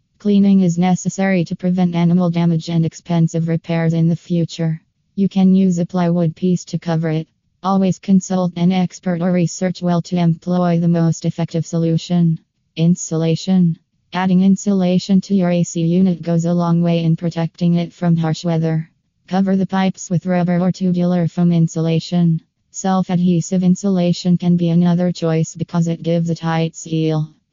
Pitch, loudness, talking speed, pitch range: 175 Hz, -17 LUFS, 160 wpm, 165-180 Hz